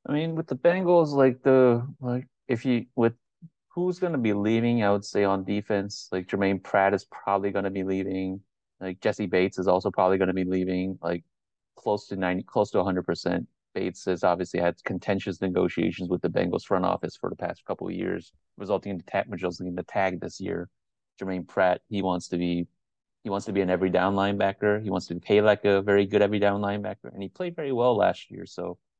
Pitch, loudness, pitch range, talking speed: 100 Hz, -26 LUFS, 95-105 Hz, 215 wpm